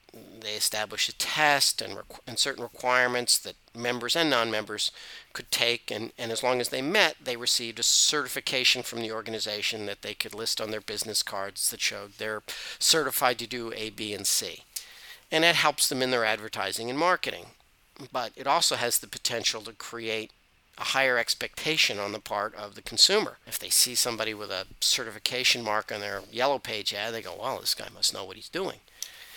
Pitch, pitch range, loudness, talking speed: 120 Hz, 110-125 Hz, -26 LUFS, 200 wpm